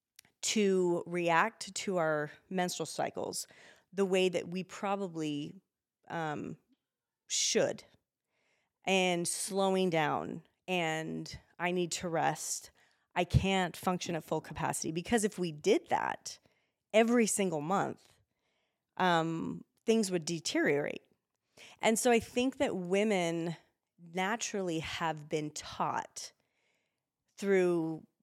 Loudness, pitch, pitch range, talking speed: -33 LUFS, 180 Hz, 165-195 Hz, 105 wpm